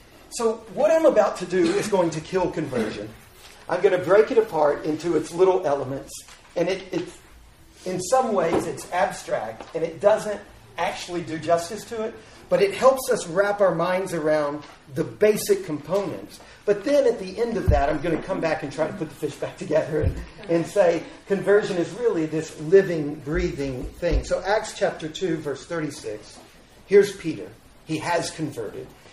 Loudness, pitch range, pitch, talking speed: -23 LUFS, 155-200 Hz, 175 Hz, 185 wpm